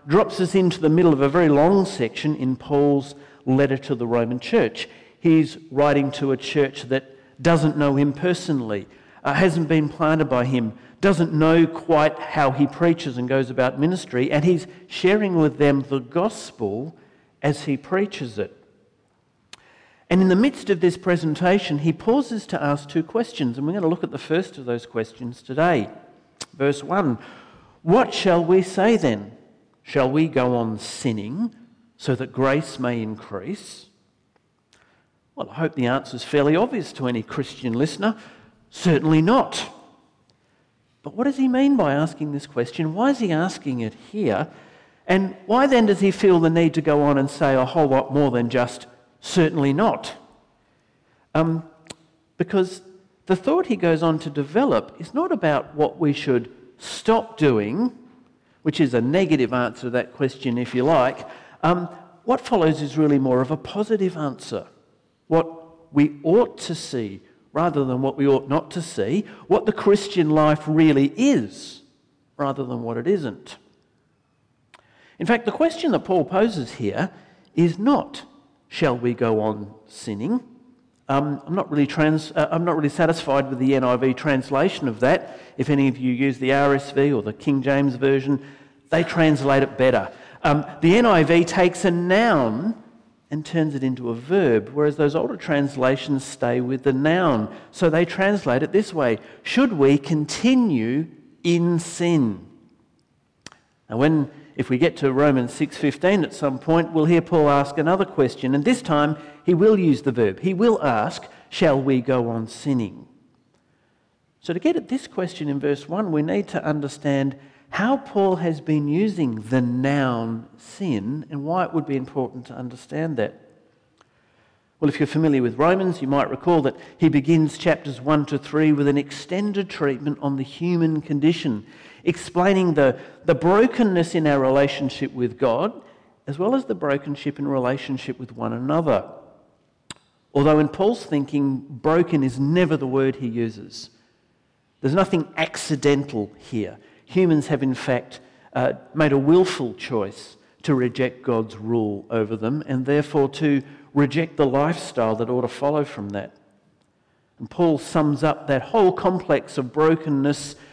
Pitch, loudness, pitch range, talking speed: 150 Hz, -21 LUFS, 135-175 Hz, 165 wpm